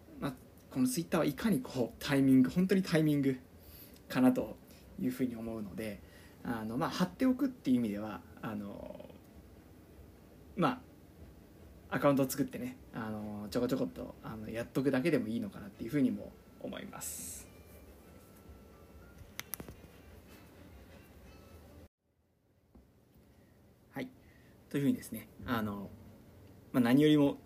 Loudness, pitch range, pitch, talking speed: -34 LUFS, 90-135 Hz, 100 Hz, 270 characters per minute